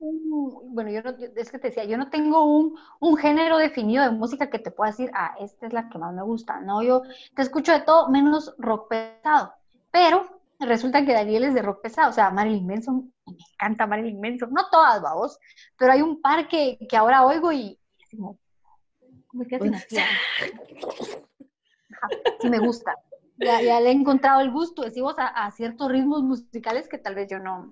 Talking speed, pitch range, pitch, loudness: 195 wpm, 225-300 Hz, 255 Hz, -22 LUFS